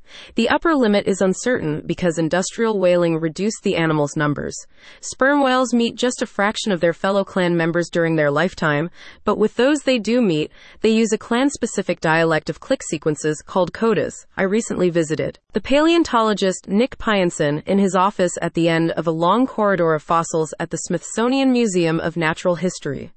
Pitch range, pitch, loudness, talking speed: 165-230 Hz, 185 Hz, -19 LUFS, 180 wpm